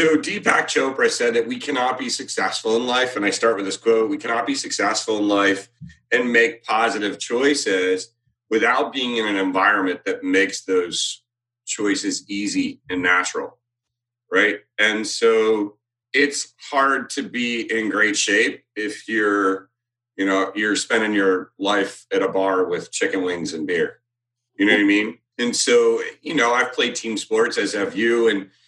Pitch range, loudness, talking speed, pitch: 100-130 Hz, -20 LUFS, 170 wpm, 115 Hz